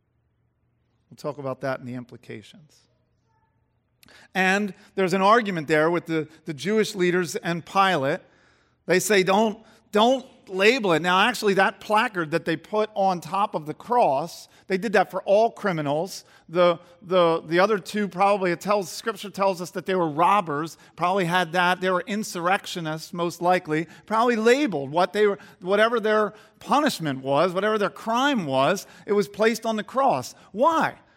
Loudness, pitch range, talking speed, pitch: -23 LUFS, 165-210 Hz, 165 wpm, 185 Hz